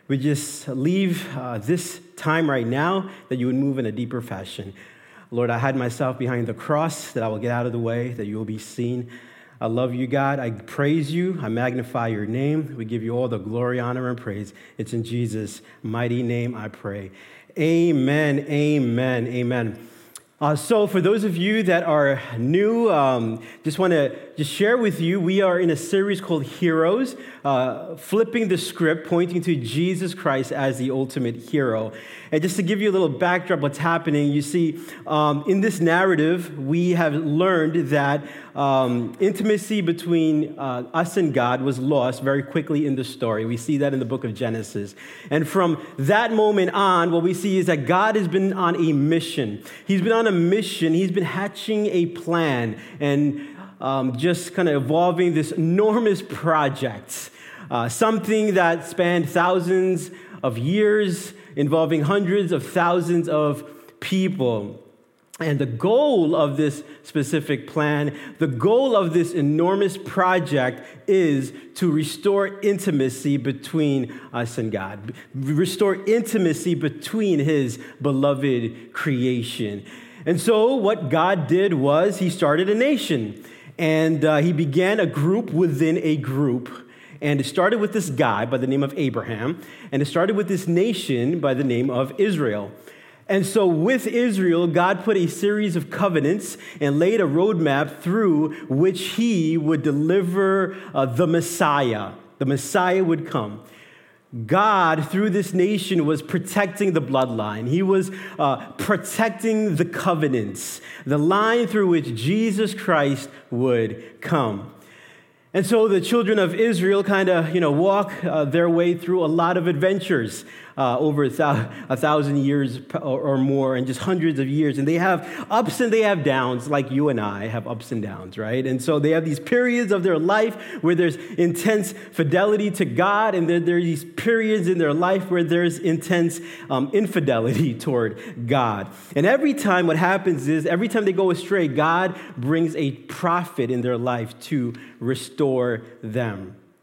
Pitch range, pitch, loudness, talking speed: 130-185 Hz, 160 Hz, -21 LUFS, 165 wpm